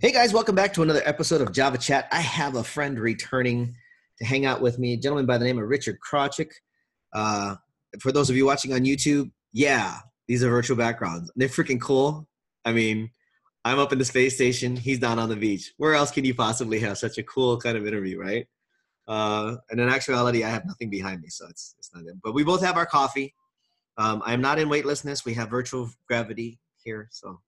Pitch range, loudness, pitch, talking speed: 115-140 Hz, -24 LUFS, 125 Hz, 220 wpm